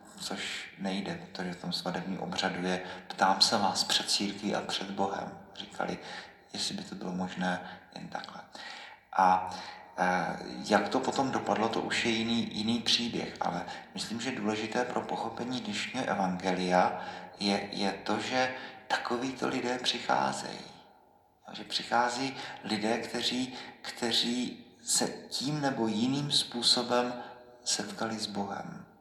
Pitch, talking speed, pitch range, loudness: 110 Hz, 130 wpm, 95-120 Hz, -31 LUFS